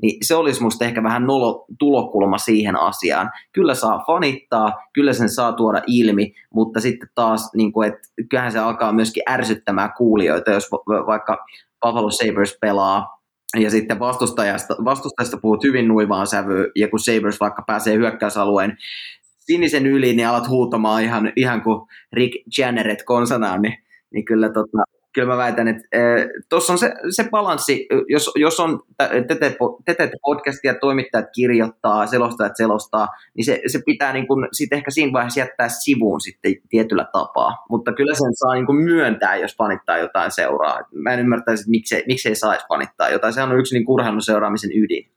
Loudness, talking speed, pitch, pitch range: -18 LUFS, 165 wpm, 115 Hz, 110-130 Hz